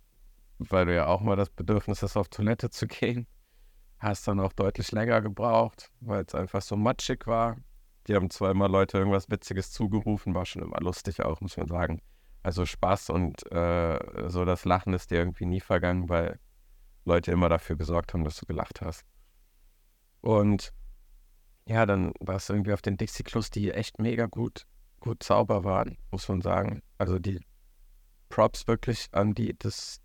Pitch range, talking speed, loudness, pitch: 90-110 Hz, 175 wpm, -29 LUFS, 100 Hz